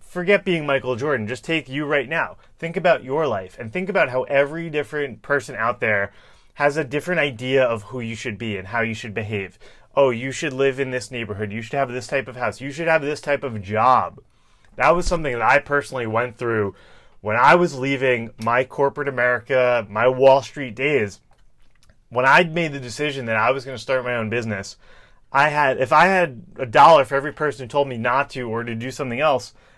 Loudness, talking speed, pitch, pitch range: -20 LUFS, 220 wpm, 130 Hz, 115-145 Hz